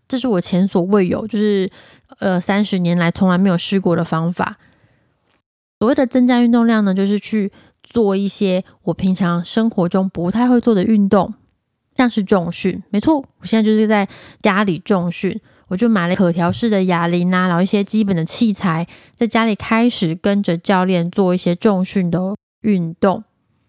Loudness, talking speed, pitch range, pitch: -17 LUFS, 265 characters per minute, 180-220 Hz, 195 Hz